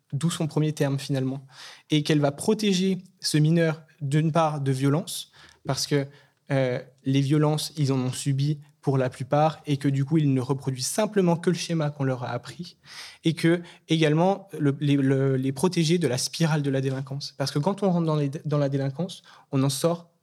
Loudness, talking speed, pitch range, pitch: -25 LUFS, 205 wpm, 140-165 Hz, 150 Hz